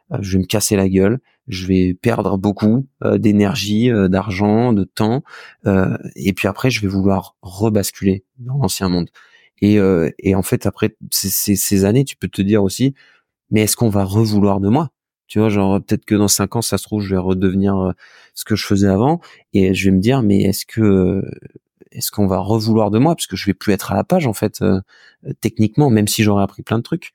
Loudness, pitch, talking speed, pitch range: -17 LUFS, 100 Hz, 210 wpm, 95-110 Hz